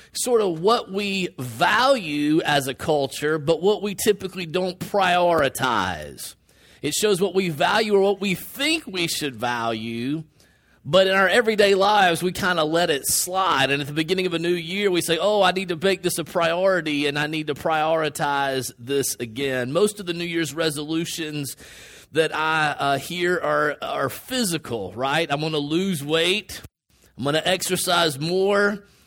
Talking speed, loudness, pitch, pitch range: 185 wpm, -22 LUFS, 170 Hz, 150-190 Hz